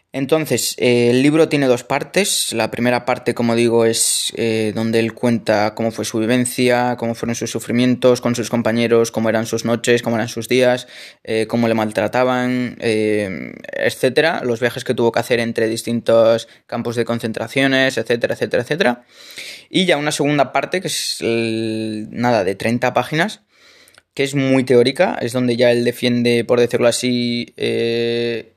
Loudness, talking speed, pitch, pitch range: -17 LUFS, 165 wpm, 120 Hz, 115-125 Hz